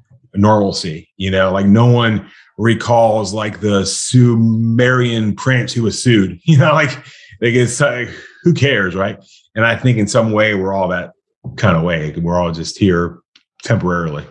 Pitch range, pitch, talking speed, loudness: 95-120 Hz, 110 Hz, 170 wpm, -14 LUFS